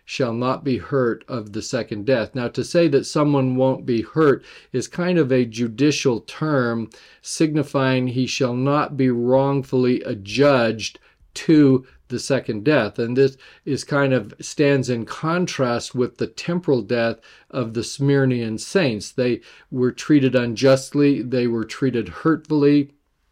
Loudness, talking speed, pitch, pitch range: -20 LUFS, 145 wpm, 130 Hz, 120-140 Hz